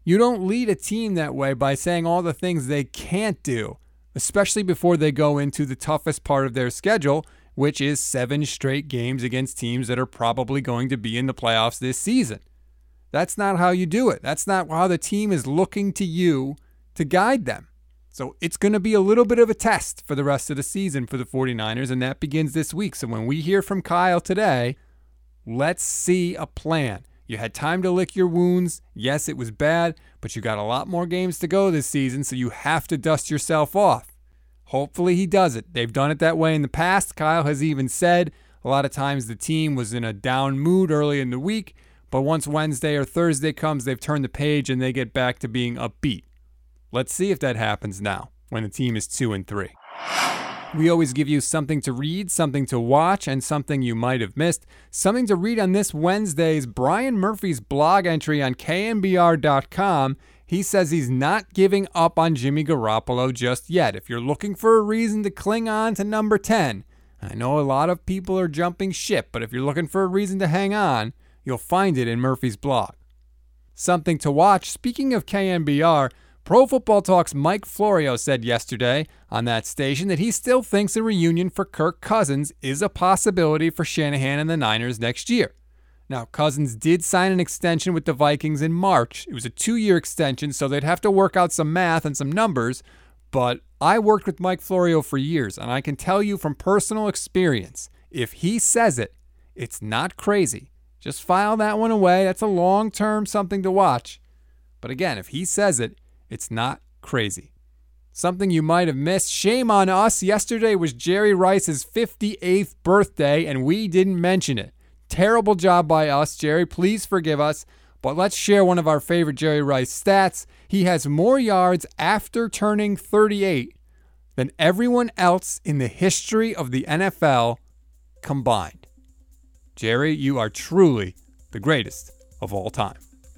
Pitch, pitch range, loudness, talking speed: 155 Hz, 130-190 Hz, -21 LUFS, 195 wpm